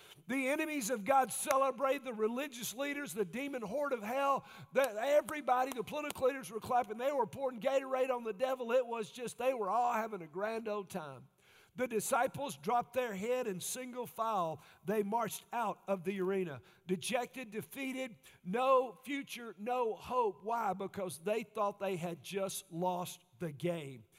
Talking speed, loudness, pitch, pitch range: 170 wpm, -36 LUFS, 235 Hz, 195-265 Hz